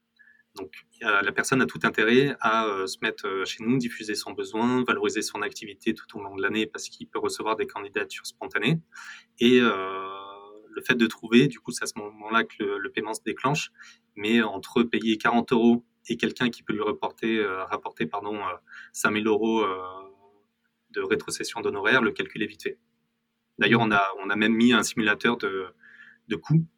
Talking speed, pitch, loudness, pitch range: 195 wpm, 110 Hz, -25 LUFS, 100-120 Hz